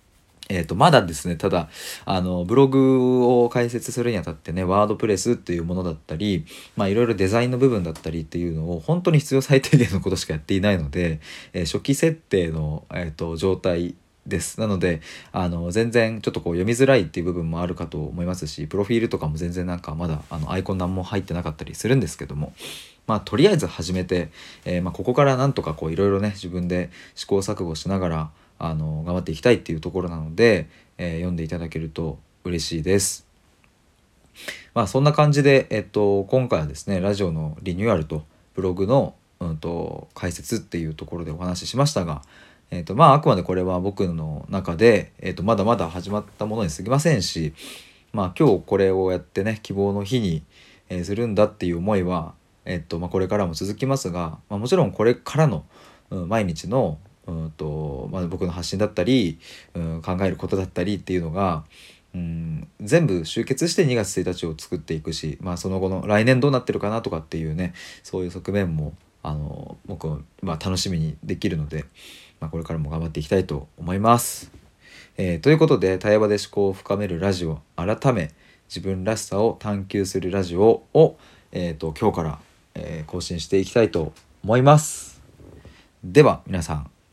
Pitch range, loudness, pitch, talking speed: 80-105 Hz, -23 LUFS, 90 Hz, 395 characters per minute